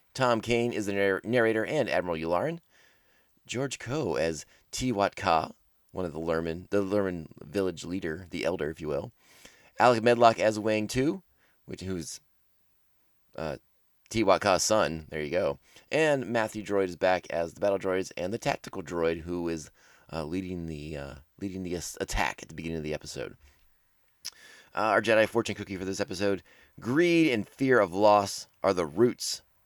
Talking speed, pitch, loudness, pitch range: 165 wpm, 95 Hz, -28 LUFS, 85-110 Hz